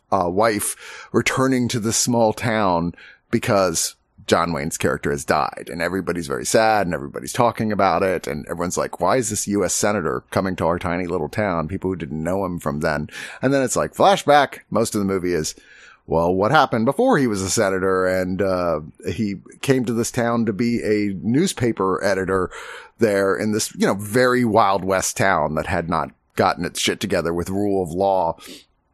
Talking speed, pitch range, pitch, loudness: 195 wpm, 90-115 Hz, 95 Hz, -20 LUFS